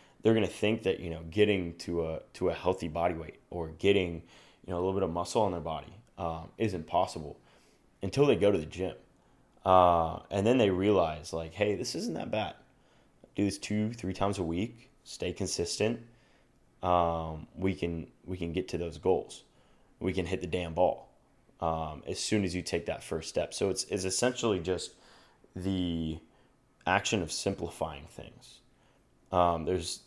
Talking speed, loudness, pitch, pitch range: 180 wpm, -31 LUFS, 90 Hz, 85-100 Hz